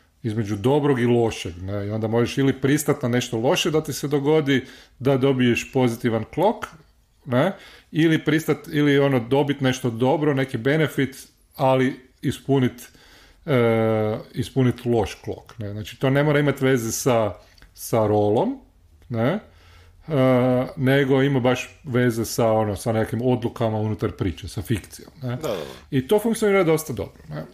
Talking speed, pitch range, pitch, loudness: 150 wpm, 110-140 Hz, 125 Hz, -22 LUFS